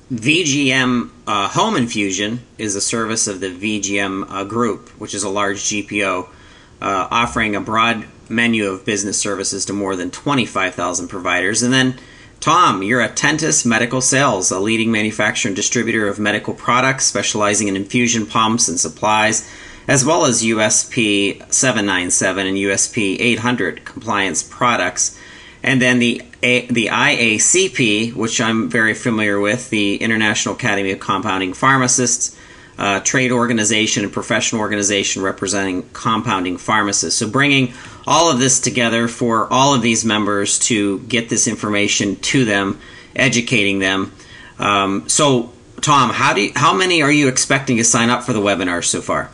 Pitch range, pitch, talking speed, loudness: 100-120 Hz, 110 Hz, 150 wpm, -16 LUFS